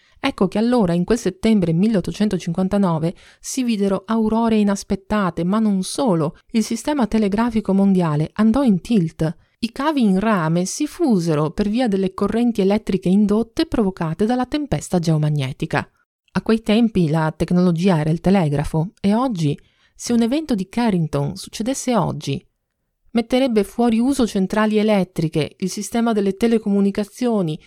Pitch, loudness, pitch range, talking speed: 205 Hz, -19 LUFS, 180-230 Hz, 135 wpm